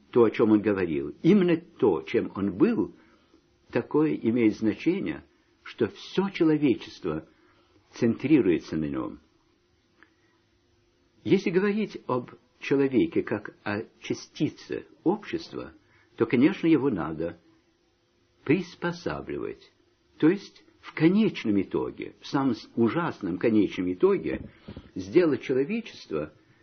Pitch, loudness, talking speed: 165 Hz, -26 LUFS, 100 wpm